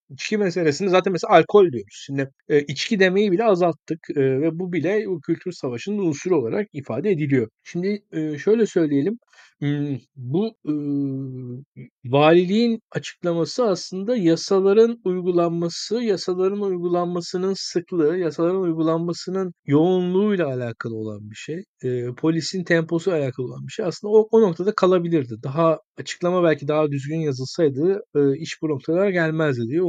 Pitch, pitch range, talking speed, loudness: 170 Hz, 145-190 Hz, 125 wpm, -21 LUFS